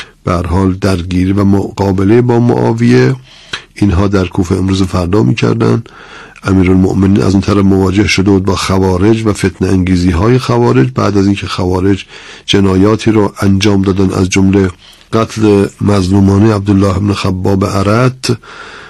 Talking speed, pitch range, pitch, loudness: 135 wpm, 95-105 Hz, 100 Hz, -10 LUFS